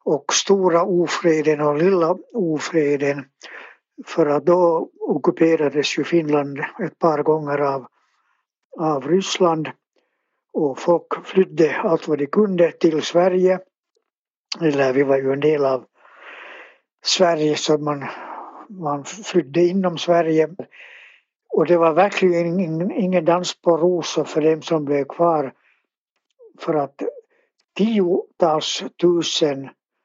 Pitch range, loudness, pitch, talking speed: 150-180 Hz, -19 LUFS, 170 Hz, 120 wpm